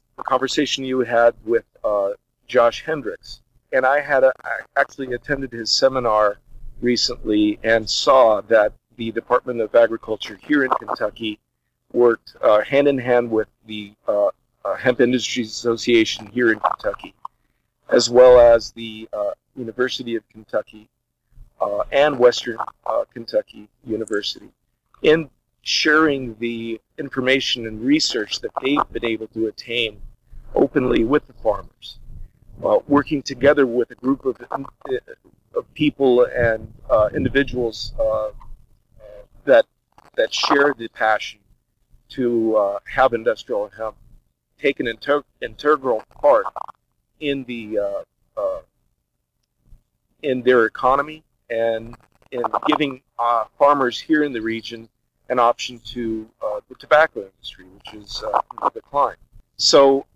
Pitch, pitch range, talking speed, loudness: 120 Hz, 110-135 Hz, 130 wpm, -20 LUFS